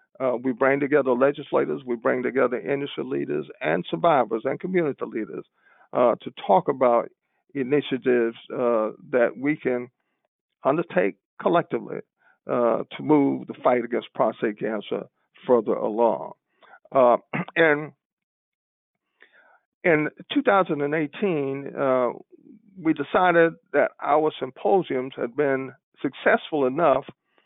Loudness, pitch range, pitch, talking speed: -24 LUFS, 130-160 Hz, 140 Hz, 110 wpm